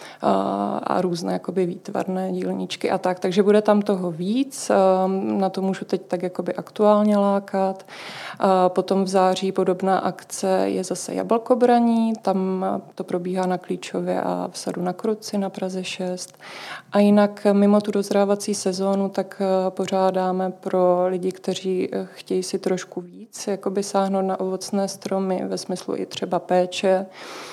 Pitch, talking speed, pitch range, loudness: 190 Hz, 145 wpm, 180-200 Hz, -22 LUFS